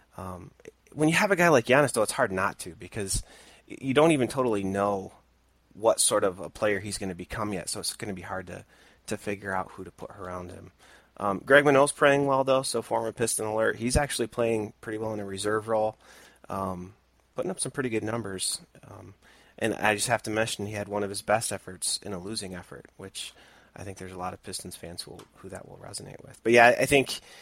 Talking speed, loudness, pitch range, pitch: 235 wpm, -26 LUFS, 95-120 Hz, 105 Hz